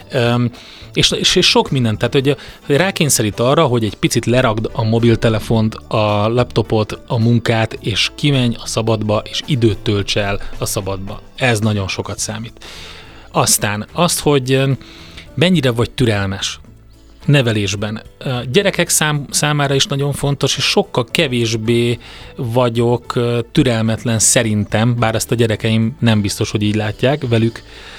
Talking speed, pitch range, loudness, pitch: 135 wpm, 110-135 Hz, -16 LUFS, 115 Hz